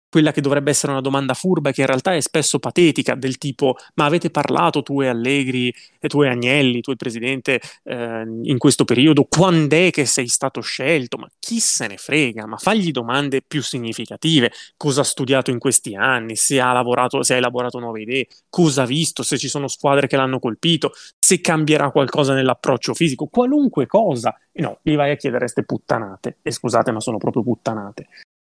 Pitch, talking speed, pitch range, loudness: 135 Hz, 200 wpm, 125-150 Hz, -18 LUFS